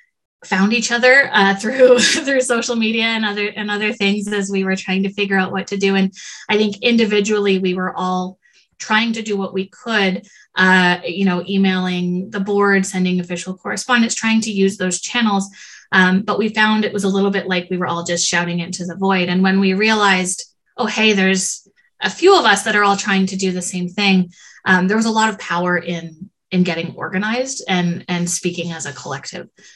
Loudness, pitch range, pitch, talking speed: -17 LUFS, 185-215 Hz, 195 Hz, 210 wpm